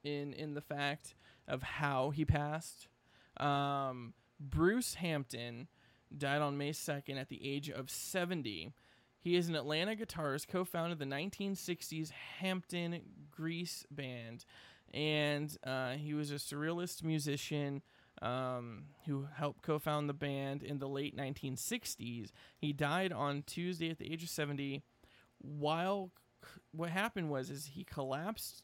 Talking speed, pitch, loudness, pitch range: 135 wpm, 145 Hz, -39 LUFS, 135-165 Hz